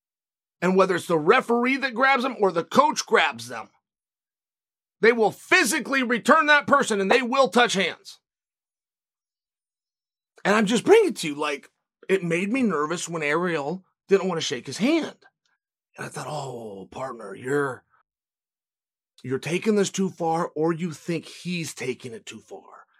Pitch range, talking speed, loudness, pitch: 165-255 Hz, 165 wpm, -22 LUFS, 190 Hz